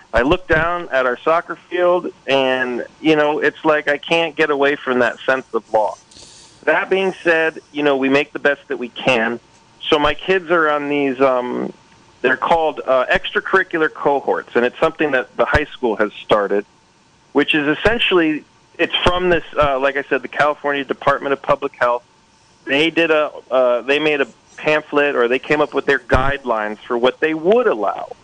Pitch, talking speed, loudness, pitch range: 145 Hz, 185 wpm, -17 LUFS, 135-160 Hz